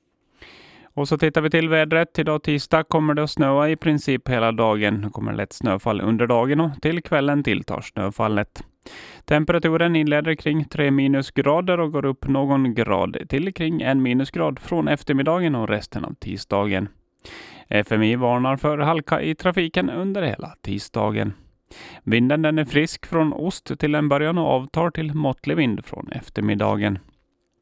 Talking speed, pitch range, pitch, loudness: 160 wpm, 110-160 Hz, 140 Hz, -21 LUFS